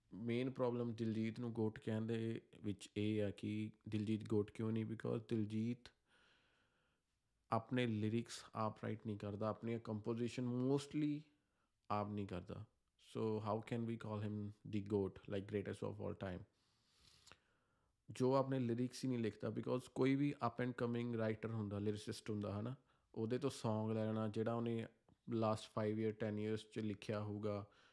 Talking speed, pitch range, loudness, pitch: 160 wpm, 105-120 Hz, -43 LUFS, 110 Hz